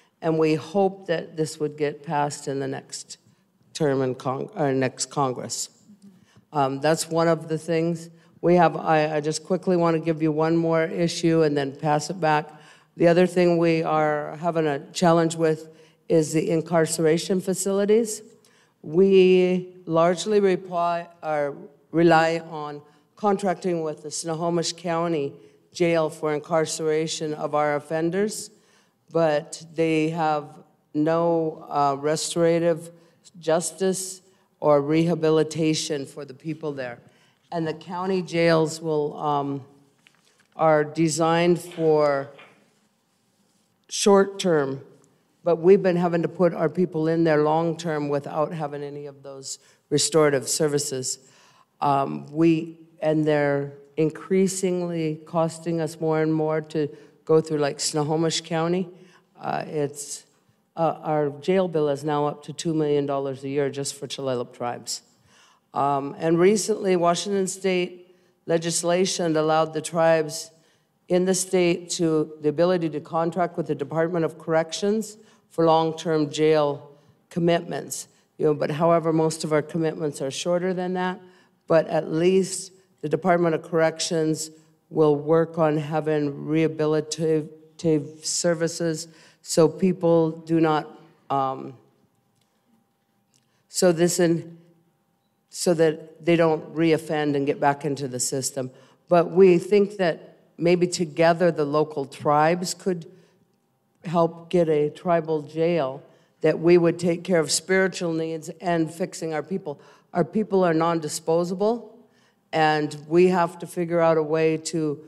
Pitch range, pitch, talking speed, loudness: 150-175 Hz, 160 Hz, 135 wpm, -23 LUFS